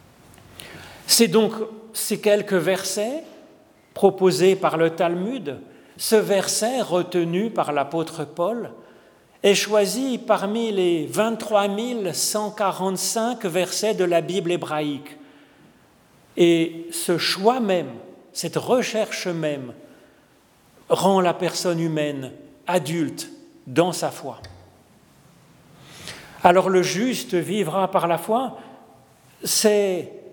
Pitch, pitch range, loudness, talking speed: 190 Hz, 170-215 Hz, -22 LUFS, 95 wpm